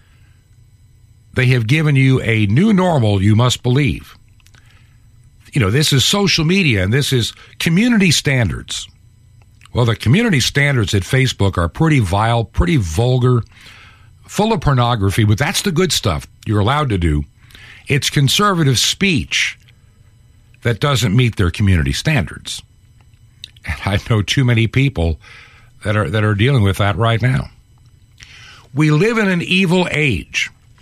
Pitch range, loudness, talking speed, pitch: 105-135 Hz, -15 LUFS, 145 wpm, 115 Hz